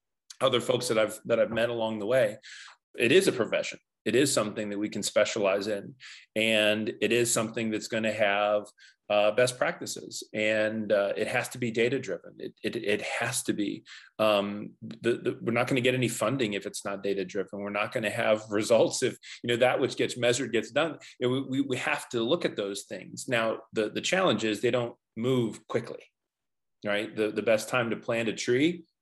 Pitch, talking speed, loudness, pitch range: 110 Hz, 220 wpm, -28 LUFS, 105-125 Hz